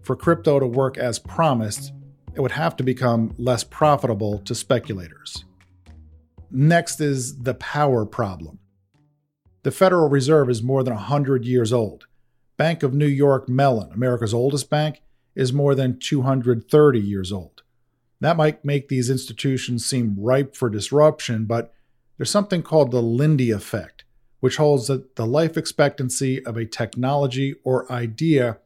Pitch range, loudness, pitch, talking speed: 115-145 Hz, -21 LUFS, 130 Hz, 145 wpm